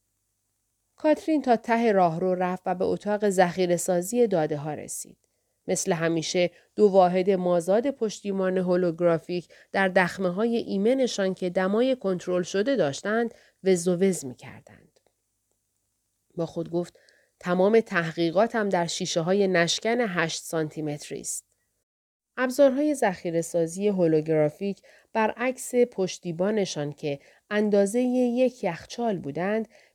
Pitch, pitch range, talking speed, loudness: 185 Hz, 165-215 Hz, 115 wpm, -25 LUFS